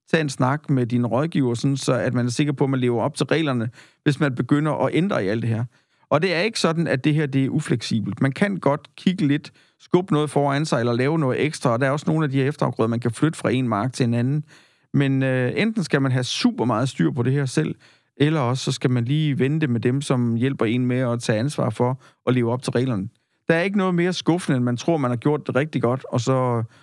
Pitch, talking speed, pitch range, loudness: 135 Hz, 270 wpm, 125-150 Hz, -22 LUFS